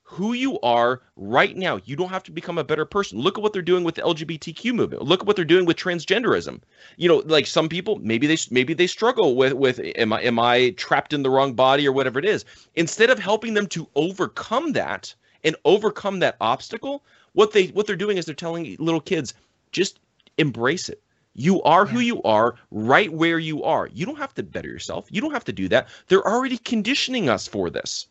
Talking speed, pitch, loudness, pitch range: 225 wpm, 170 Hz, -21 LUFS, 150-210 Hz